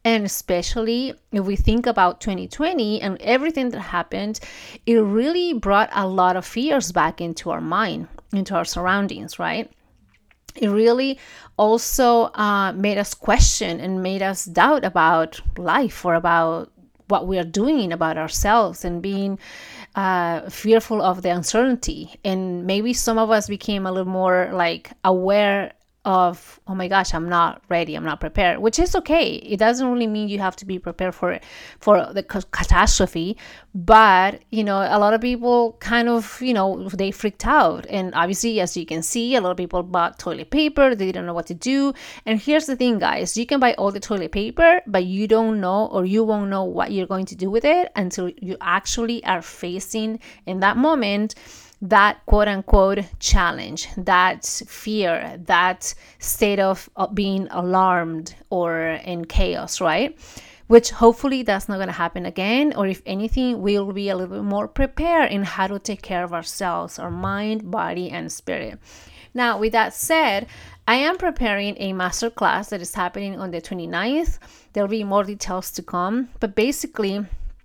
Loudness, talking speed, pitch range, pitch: -20 LUFS, 175 wpm, 185-230 Hz, 200 Hz